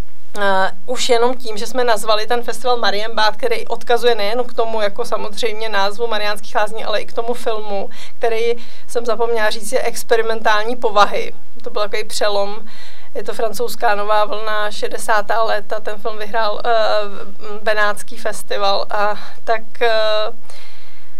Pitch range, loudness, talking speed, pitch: 210-235 Hz, -19 LUFS, 150 wpm, 220 Hz